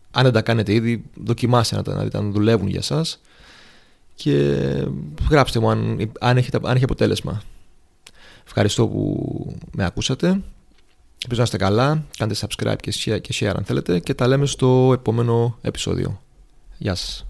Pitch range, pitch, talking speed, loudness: 100-130 Hz, 115 Hz, 155 wpm, -20 LUFS